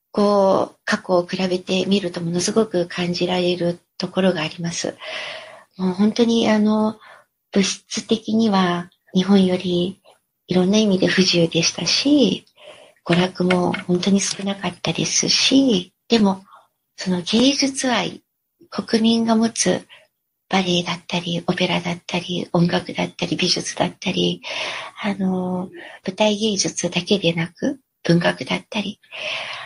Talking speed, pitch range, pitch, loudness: 260 characters per minute, 175-220 Hz, 190 Hz, -20 LUFS